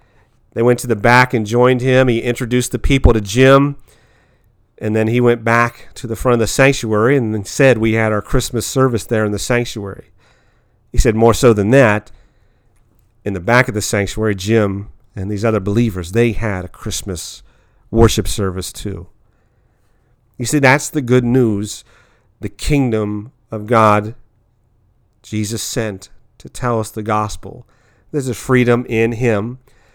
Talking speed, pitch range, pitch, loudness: 165 wpm, 105-120 Hz, 115 Hz, -15 LUFS